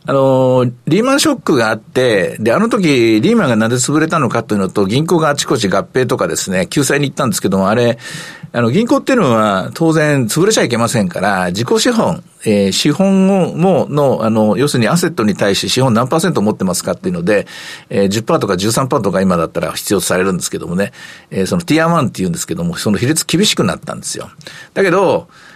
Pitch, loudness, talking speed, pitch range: 155 Hz, -14 LUFS, 450 characters per minute, 120-180 Hz